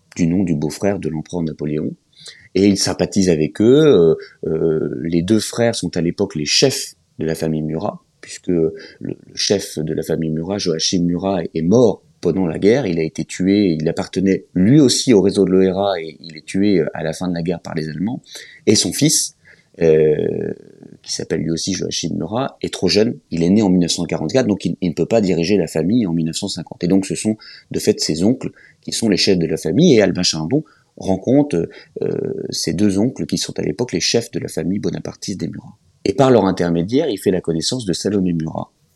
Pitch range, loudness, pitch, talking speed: 80-95 Hz, -17 LUFS, 85 Hz, 215 wpm